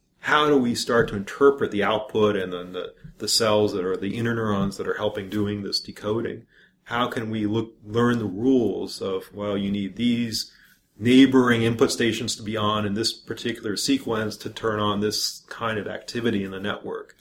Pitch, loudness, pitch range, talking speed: 110 Hz, -24 LUFS, 105-120 Hz, 195 wpm